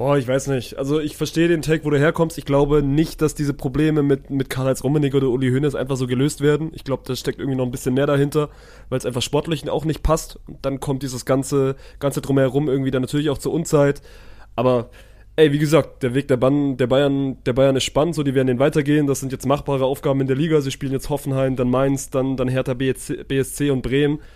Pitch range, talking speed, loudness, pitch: 130-150 Hz, 245 wpm, -20 LUFS, 140 Hz